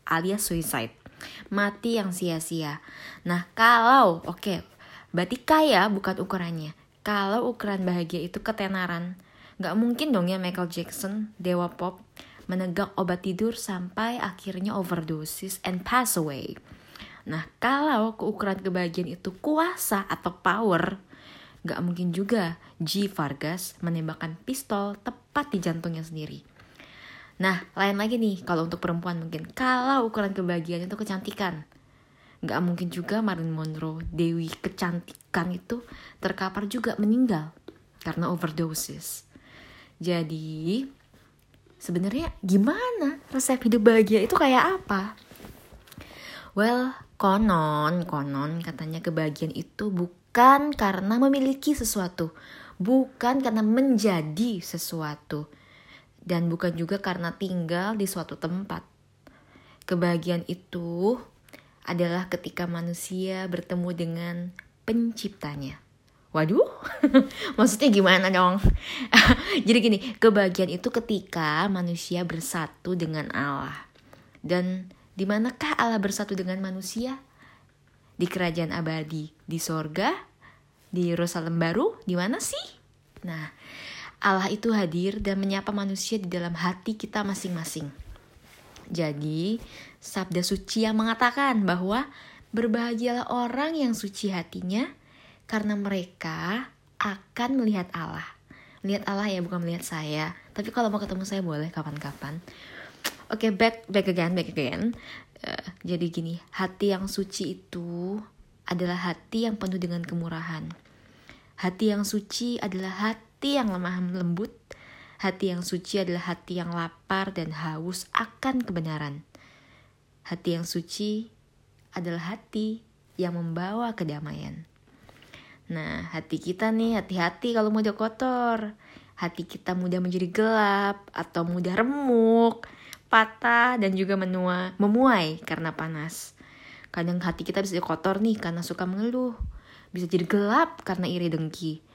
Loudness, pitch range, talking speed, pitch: -27 LUFS, 170-215 Hz, 120 wpm, 185 Hz